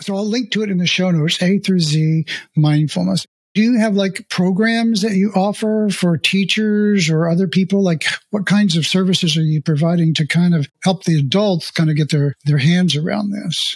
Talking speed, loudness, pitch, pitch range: 210 wpm, -16 LUFS, 185 Hz, 160-205 Hz